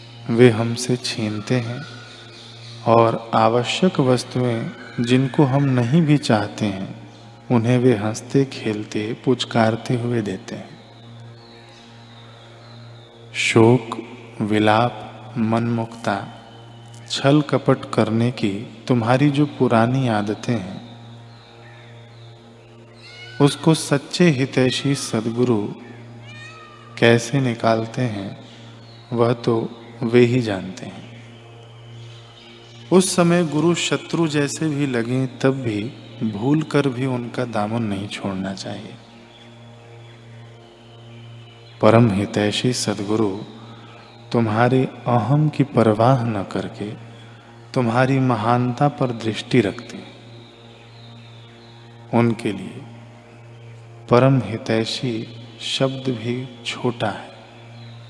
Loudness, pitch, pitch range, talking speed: -20 LUFS, 115 Hz, 115-125 Hz, 90 wpm